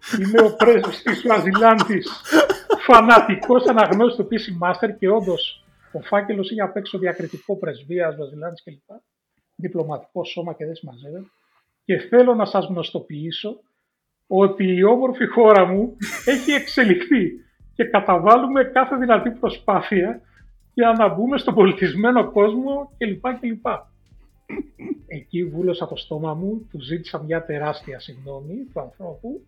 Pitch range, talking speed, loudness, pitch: 175-230 Hz, 125 wpm, -18 LUFS, 205 Hz